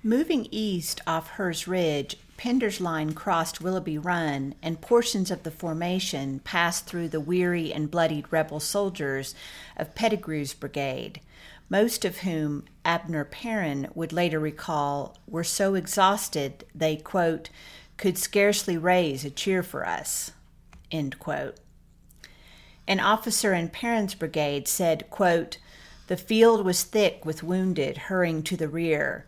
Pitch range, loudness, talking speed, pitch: 155-190 Hz, -27 LUFS, 135 wpm, 170 Hz